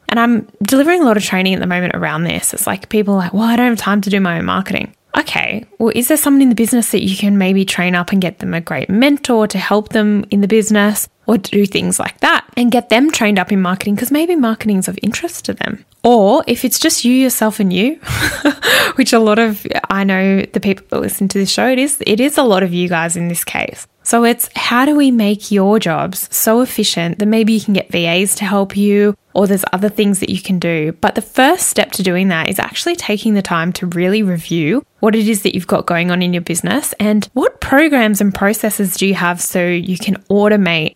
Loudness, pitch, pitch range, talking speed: -14 LUFS, 205 Hz, 190-230 Hz, 250 wpm